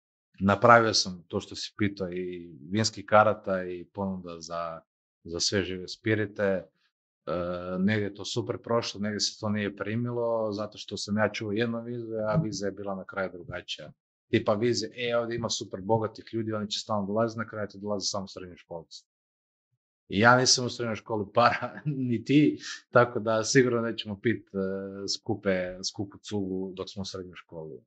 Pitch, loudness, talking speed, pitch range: 105 Hz, -28 LUFS, 170 wpm, 95-115 Hz